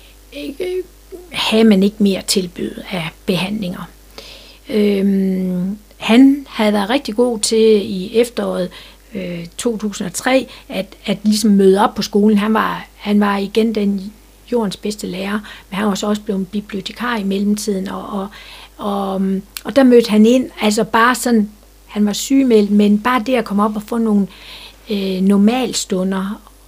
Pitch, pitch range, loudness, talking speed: 210 Hz, 195-230 Hz, -16 LUFS, 155 wpm